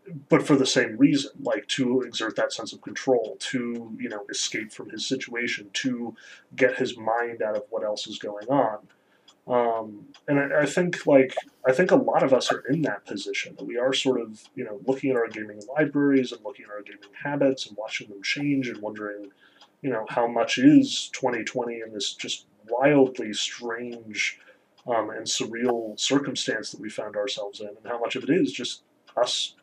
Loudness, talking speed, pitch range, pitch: -25 LUFS, 200 wpm, 110-140 Hz, 125 Hz